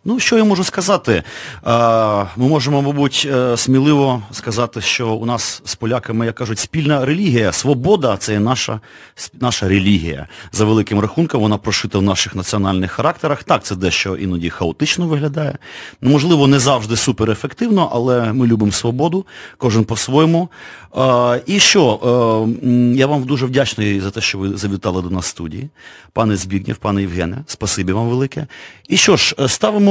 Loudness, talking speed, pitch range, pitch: -15 LUFS, 155 wpm, 105-140 Hz, 120 Hz